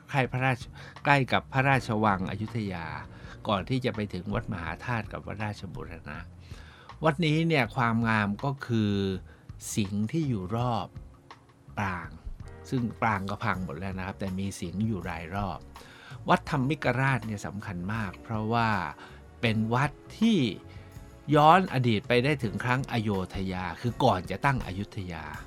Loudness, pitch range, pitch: -28 LUFS, 95-120 Hz, 105 Hz